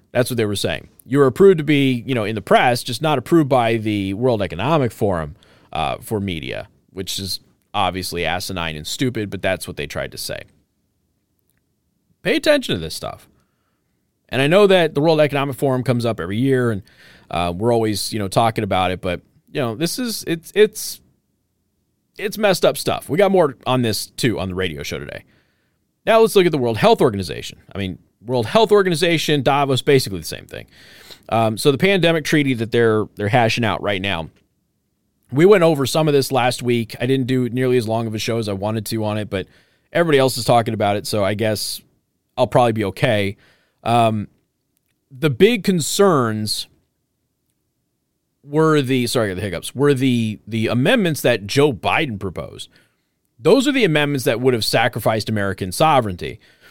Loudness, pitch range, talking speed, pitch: -18 LUFS, 100-145 Hz, 190 wpm, 120 Hz